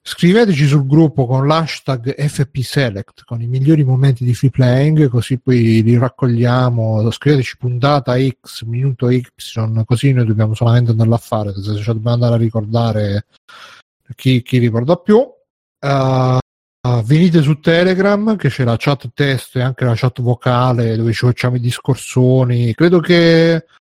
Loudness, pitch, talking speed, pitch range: -14 LUFS, 125 Hz, 155 wpm, 120-145 Hz